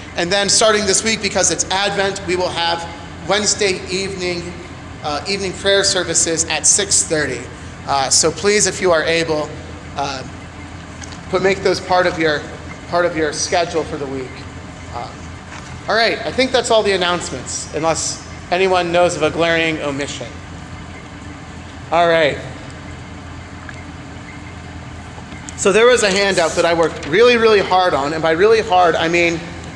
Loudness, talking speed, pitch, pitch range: -16 LUFS, 155 wpm, 170 Hz, 140-190 Hz